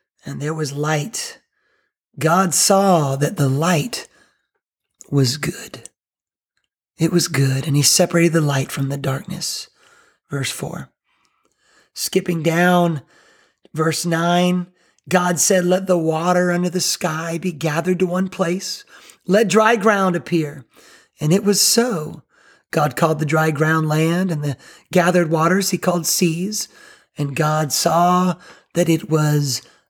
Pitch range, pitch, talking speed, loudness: 155-185 Hz, 170 Hz, 135 wpm, -18 LUFS